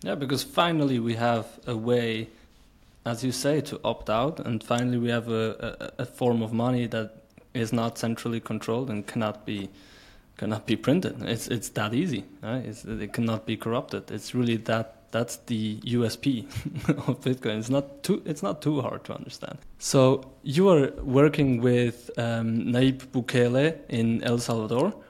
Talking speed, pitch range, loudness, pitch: 170 wpm, 110-130 Hz, -27 LUFS, 120 Hz